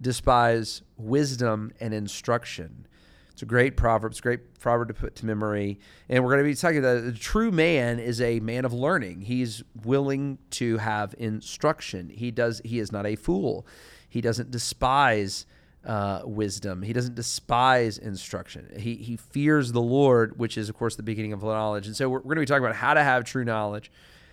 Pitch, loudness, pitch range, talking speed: 115 Hz, -26 LUFS, 110-130 Hz, 190 wpm